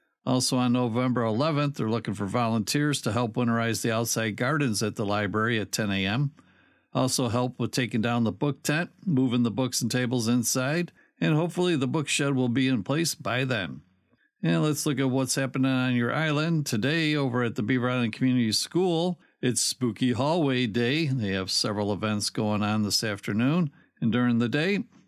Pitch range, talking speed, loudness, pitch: 115-145 Hz, 185 wpm, -26 LUFS, 125 Hz